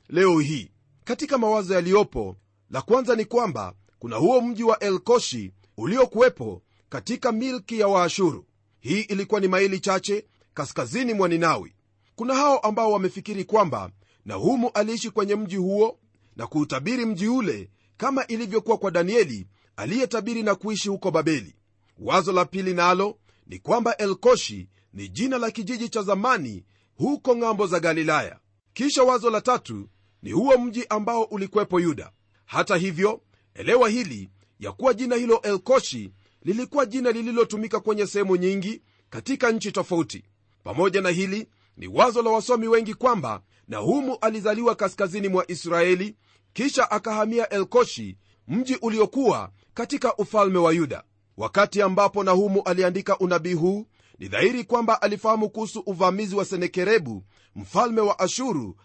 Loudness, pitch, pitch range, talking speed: -23 LUFS, 200 Hz, 155-230 Hz, 140 wpm